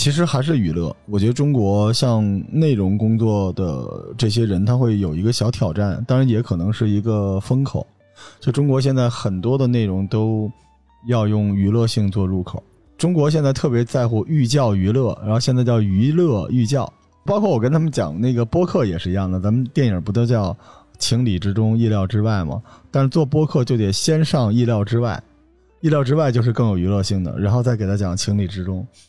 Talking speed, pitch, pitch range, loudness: 300 characters per minute, 115 Hz, 100-130 Hz, -19 LUFS